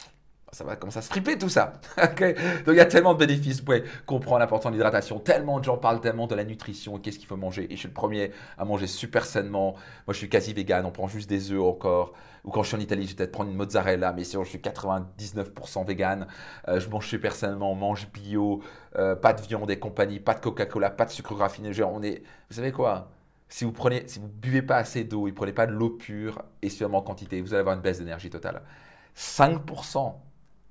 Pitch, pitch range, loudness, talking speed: 105 Hz, 100-120 Hz, -27 LUFS, 240 wpm